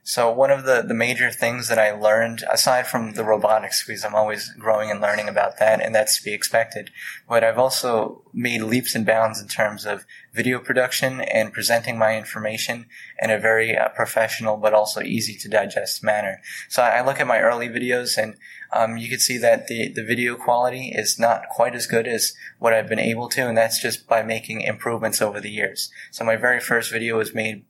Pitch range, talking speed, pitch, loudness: 110-120 Hz, 215 wpm, 115 Hz, -21 LUFS